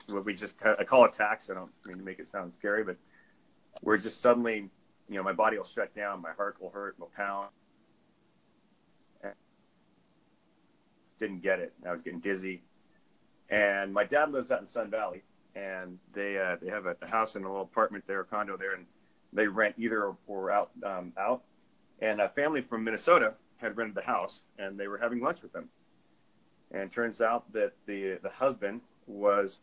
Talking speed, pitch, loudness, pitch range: 190 wpm, 100 Hz, -31 LUFS, 95-110 Hz